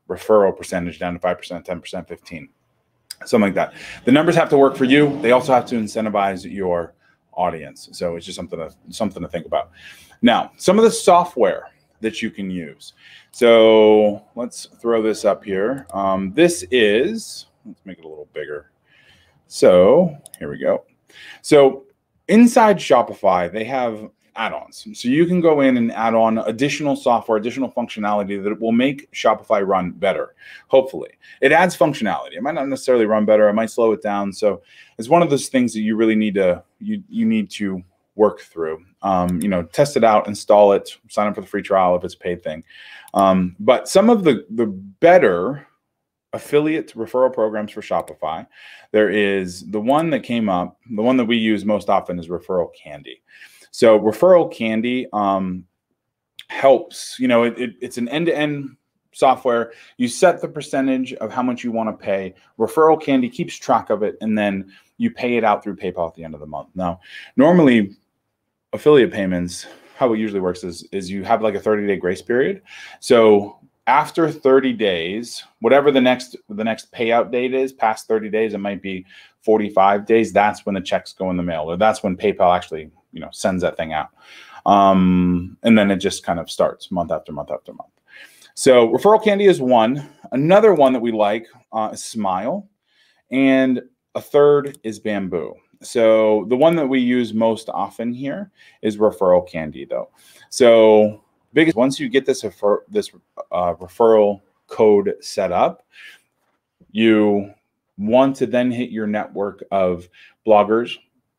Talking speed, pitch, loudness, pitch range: 180 wpm, 115 Hz, -18 LUFS, 100-140 Hz